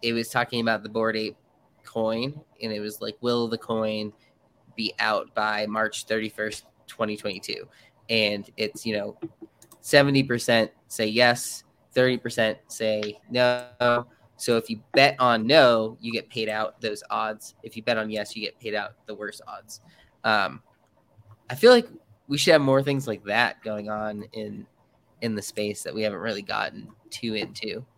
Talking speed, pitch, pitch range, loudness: 180 wpm, 110 Hz, 110-120 Hz, -25 LUFS